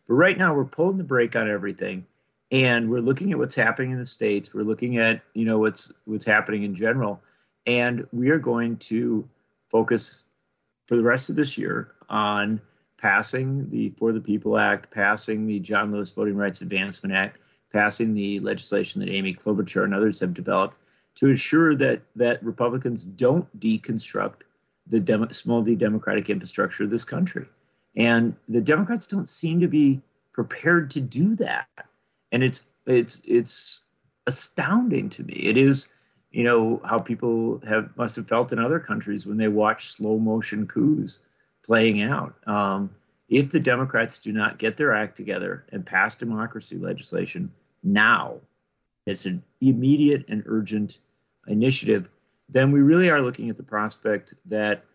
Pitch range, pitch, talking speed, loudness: 105-135 Hz, 115 Hz, 165 wpm, -23 LUFS